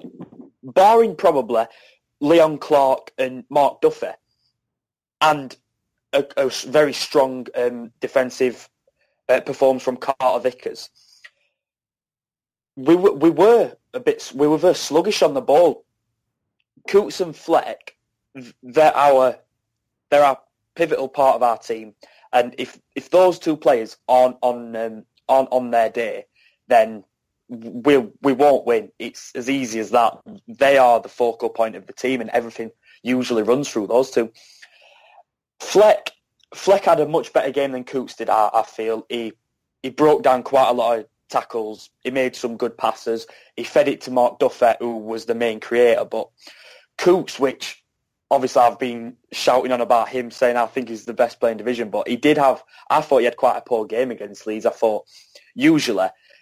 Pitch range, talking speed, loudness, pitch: 120-150 Hz, 170 wpm, -19 LUFS, 130 Hz